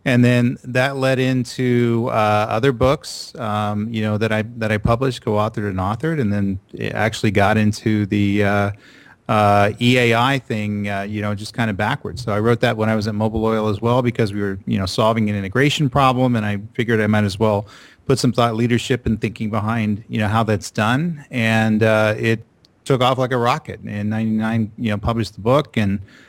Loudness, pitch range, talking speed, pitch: -19 LUFS, 105-125 Hz, 215 wpm, 110 Hz